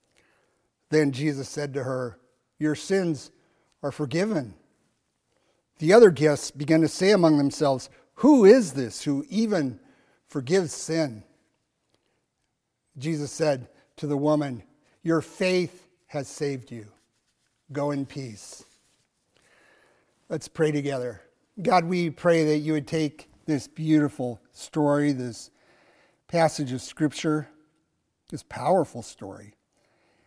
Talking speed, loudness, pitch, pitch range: 115 wpm, -24 LUFS, 150 Hz, 135-160 Hz